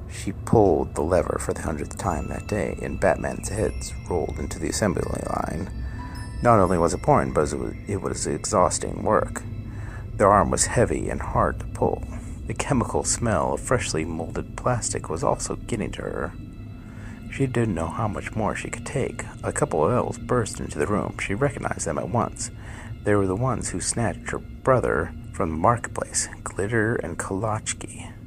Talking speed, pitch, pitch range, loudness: 185 wpm, 110 Hz, 95-115 Hz, -25 LUFS